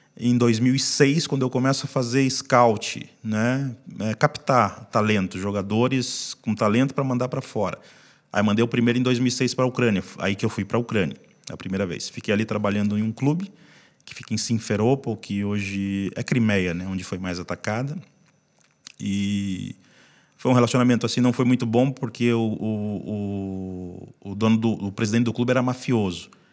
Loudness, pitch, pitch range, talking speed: -23 LUFS, 115 Hz, 100-125 Hz, 175 wpm